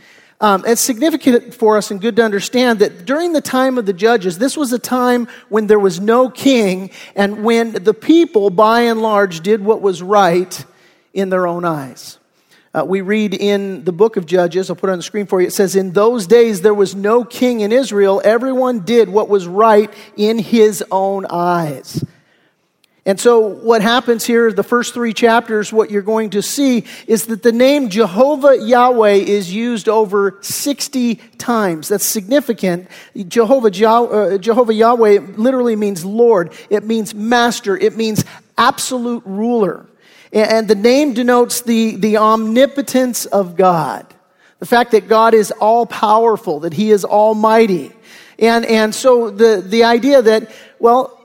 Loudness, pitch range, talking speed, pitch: -14 LUFS, 200-240 Hz, 170 wpm, 220 Hz